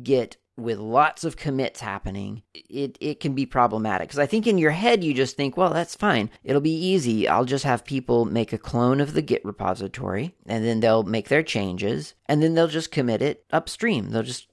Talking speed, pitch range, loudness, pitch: 215 wpm, 110-150 Hz, -23 LUFS, 130 Hz